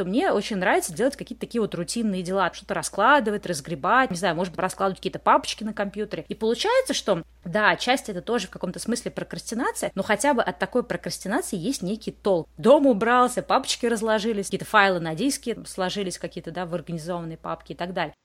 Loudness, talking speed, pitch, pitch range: -24 LUFS, 195 wpm, 200 Hz, 180-235 Hz